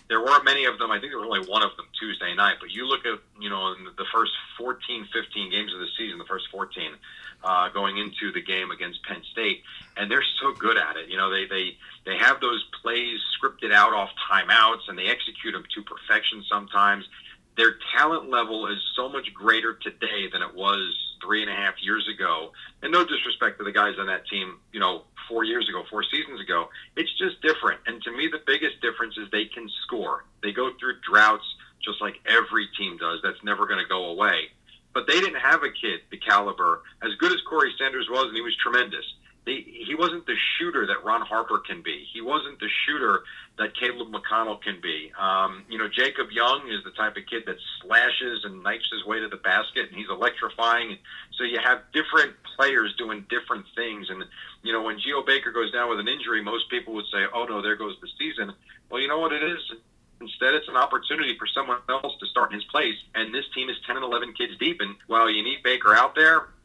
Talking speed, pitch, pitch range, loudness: 225 wpm, 115 Hz, 100-155 Hz, -24 LUFS